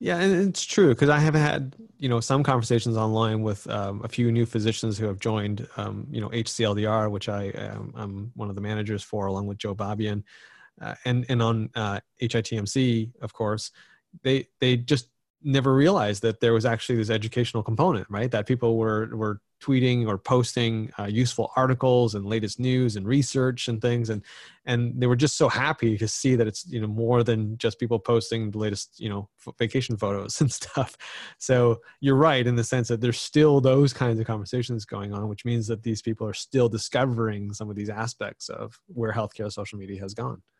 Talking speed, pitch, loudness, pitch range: 205 wpm, 115 Hz, -25 LUFS, 105-125 Hz